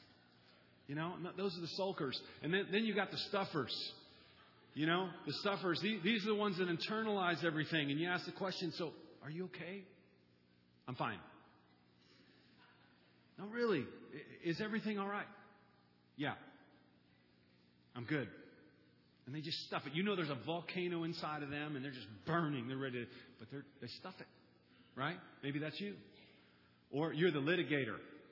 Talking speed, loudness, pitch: 165 wpm, -40 LUFS, 150 Hz